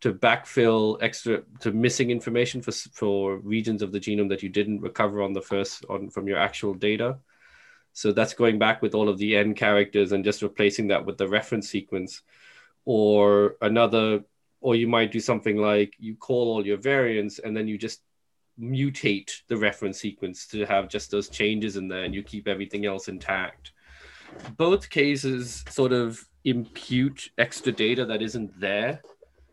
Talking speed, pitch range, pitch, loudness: 175 wpm, 100-115 Hz, 105 Hz, -25 LUFS